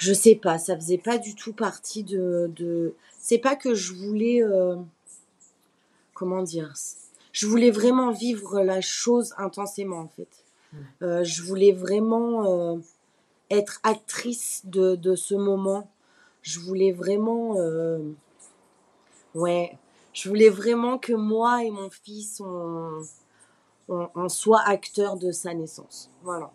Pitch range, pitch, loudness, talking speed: 175-220 Hz, 195 Hz, -24 LUFS, 140 wpm